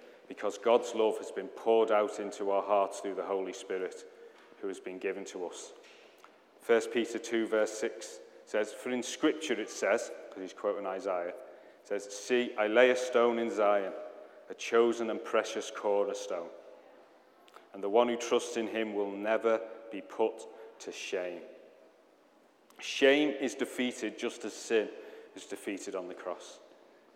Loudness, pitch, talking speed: -32 LUFS, 125 Hz, 165 wpm